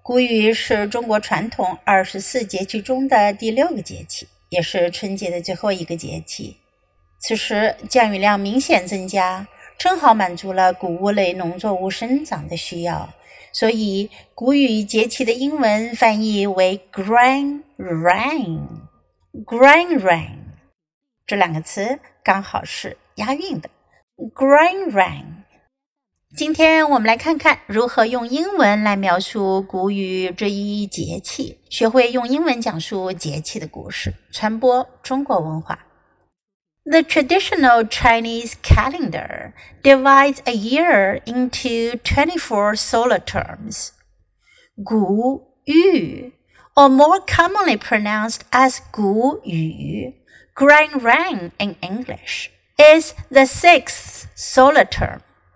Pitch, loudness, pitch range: 225 Hz, -17 LUFS, 190-270 Hz